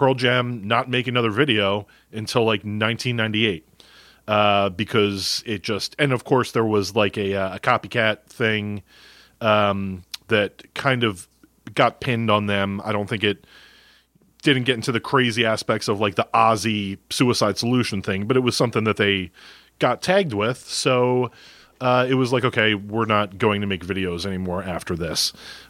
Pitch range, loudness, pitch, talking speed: 100-125 Hz, -21 LUFS, 110 Hz, 170 wpm